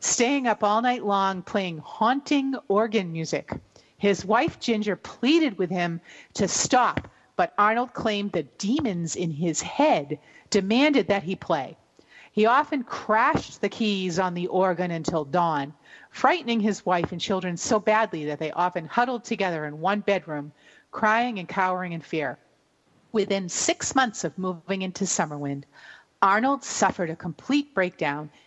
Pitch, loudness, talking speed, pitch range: 195 Hz, -25 LUFS, 150 wpm, 175-220 Hz